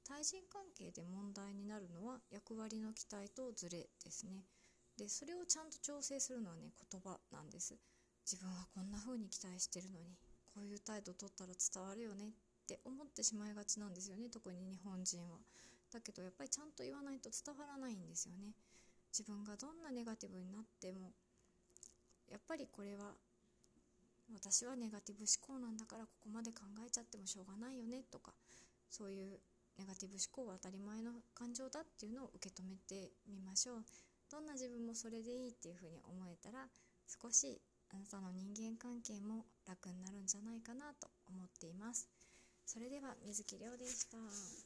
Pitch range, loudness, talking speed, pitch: 190-245 Hz, -48 LUFS, 375 characters per minute, 210 Hz